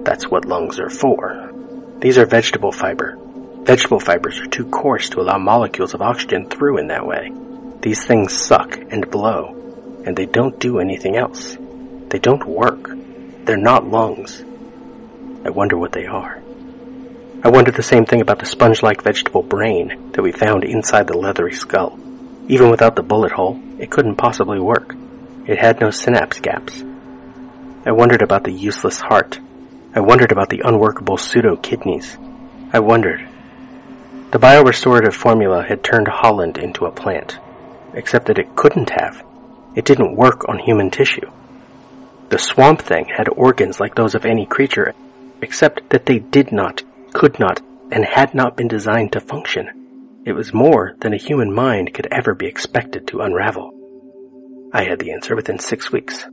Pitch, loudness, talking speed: 240 Hz, -15 LUFS, 165 wpm